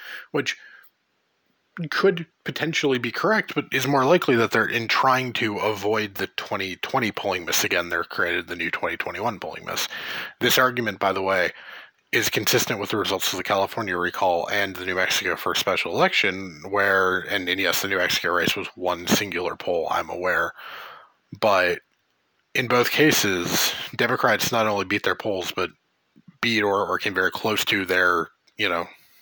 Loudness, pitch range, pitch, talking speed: -22 LUFS, 100-140 Hz, 115 Hz, 175 wpm